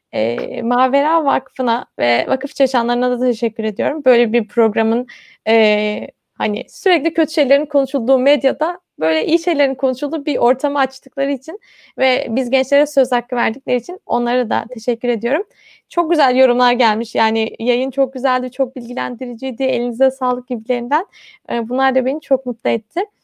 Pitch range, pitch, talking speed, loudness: 240-280 Hz, 260 Hz, 145 wpm, -16 LUFS